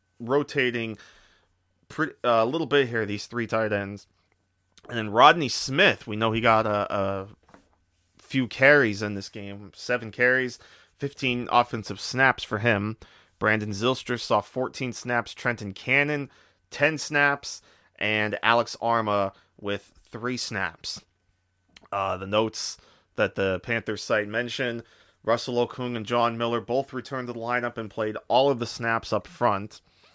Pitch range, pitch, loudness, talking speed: 100-125 Hz, 115 Hz, -25 LUFS, 145 wpm